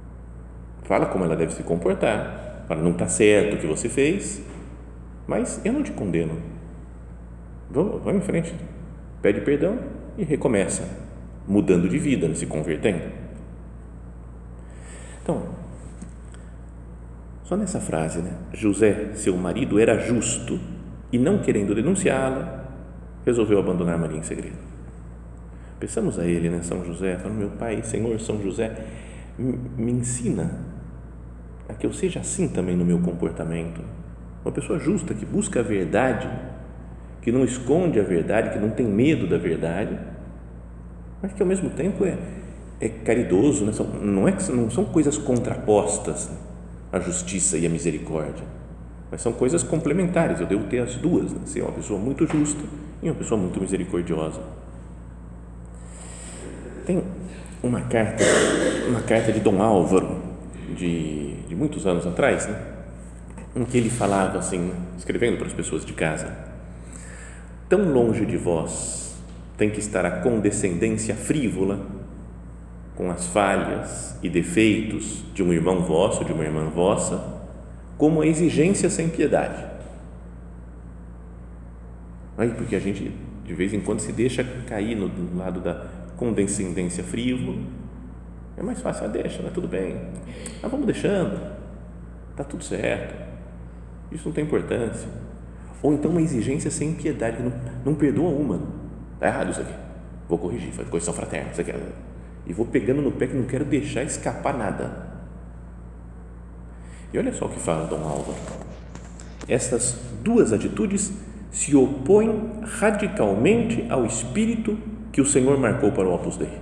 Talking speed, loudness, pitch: 145 wpm, -24 LUFS, 85 Hz